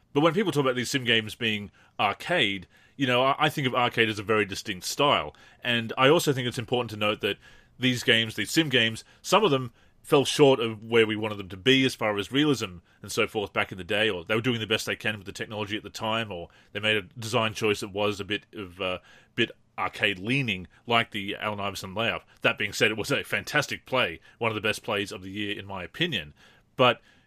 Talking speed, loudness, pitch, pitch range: 245 wpm, -26 LUFS, 110 Hz, 105-125 Hz